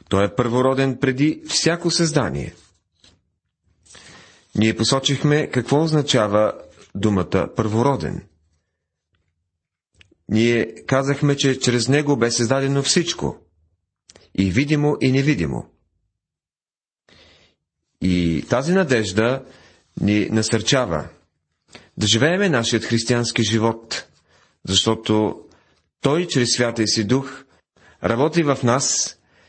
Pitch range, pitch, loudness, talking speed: 90-135 Hz, 115 Hz, -19 LUFS, 90 wpm